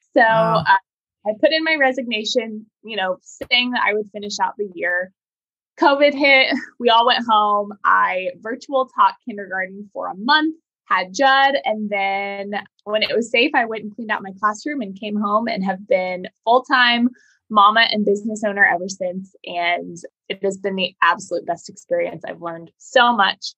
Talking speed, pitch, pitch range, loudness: 180 wpm, 215 Hz, 200-260 Hz, -18 LUFS